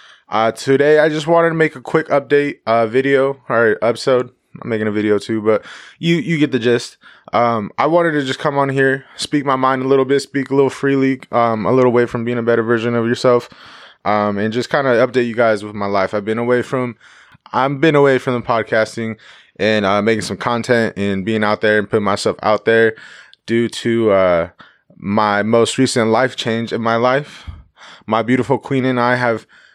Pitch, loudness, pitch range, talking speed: 120 Hz, -16 LUFS, 110-135 Hz, 215 wpm